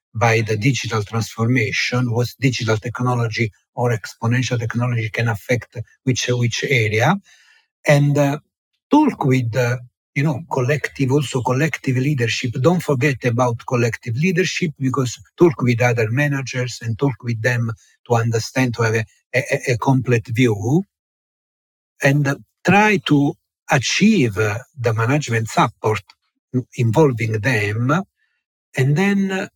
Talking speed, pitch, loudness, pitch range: 130 wpm, 125 Hz, -19 LUFS, 115-145 Hz